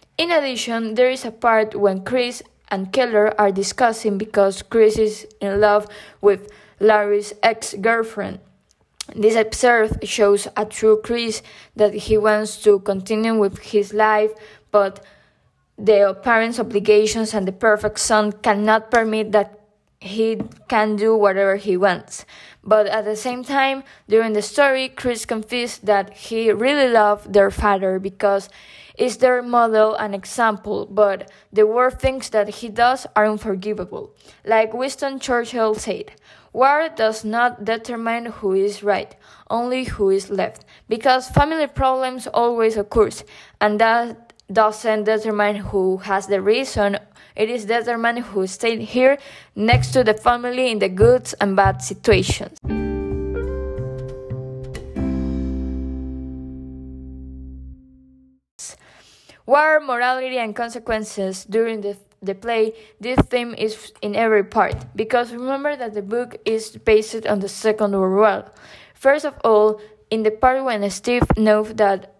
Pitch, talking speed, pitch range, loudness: 215 Hz, 135 wpm, 200-235 Hz, -19 LUFS